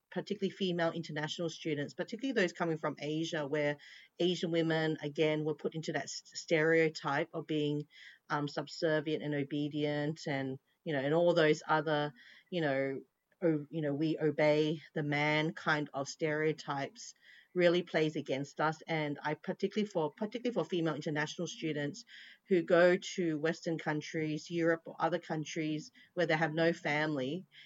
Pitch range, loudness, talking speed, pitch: 150-170 Hz, -34 LUFS, 150 wpm, 155 Hz